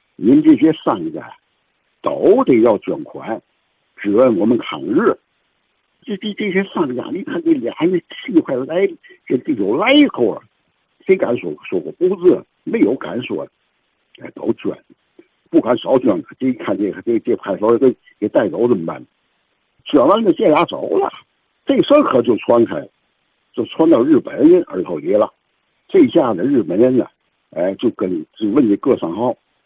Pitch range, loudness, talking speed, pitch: 295-360 Hz, -16 LUFS, 230 characters per minute, 325 Hz